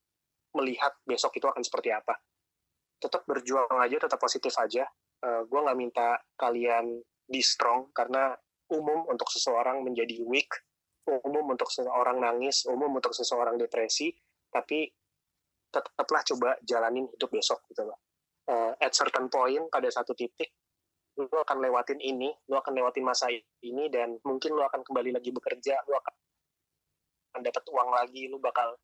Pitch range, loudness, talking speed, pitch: 120-145 Hz, -30 LUFS, 145 wpm, 130 Hz